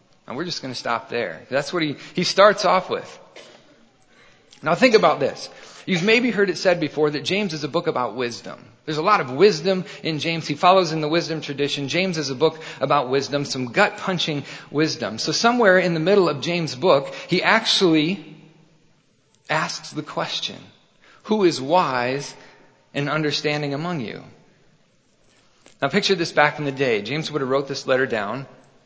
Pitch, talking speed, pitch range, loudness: 155 Hz, 185 wpm, 140-180 Hz, -21 LUFS